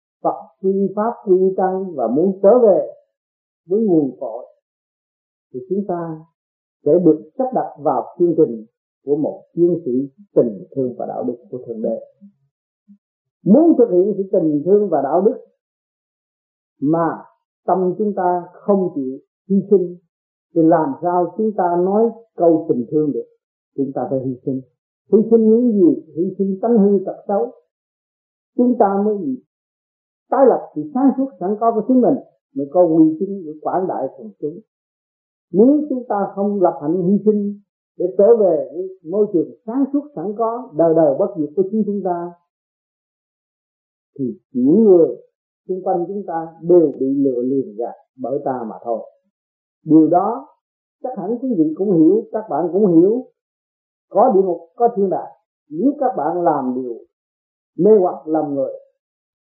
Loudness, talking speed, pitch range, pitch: -17 LUFS, 165 wpm, 160-230 Hz, 190 Hz